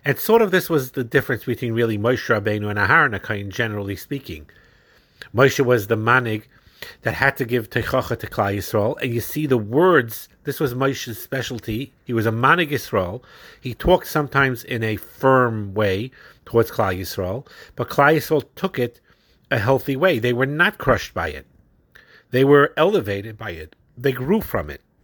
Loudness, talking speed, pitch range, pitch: -20 LUFS, 180 wpm, 110-140 Hz, 125 Hz